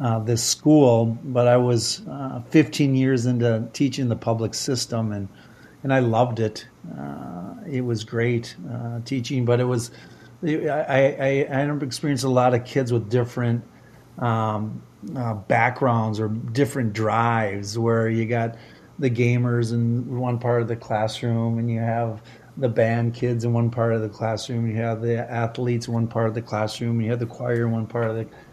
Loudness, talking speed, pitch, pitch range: -23 LUFS, 185 wpm, 120 Hz, 115-125 Hz